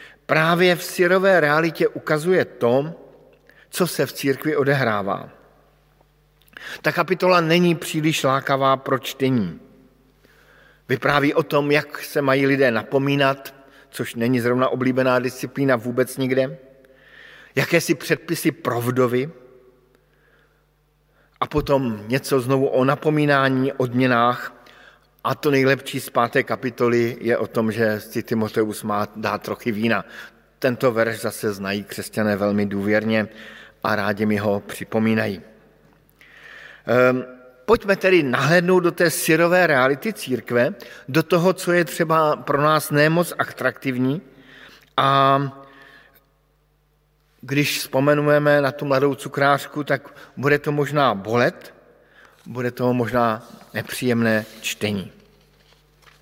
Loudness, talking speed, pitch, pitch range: -20 LUFS, 115 wpm, 135 Hz, 120-150 Hz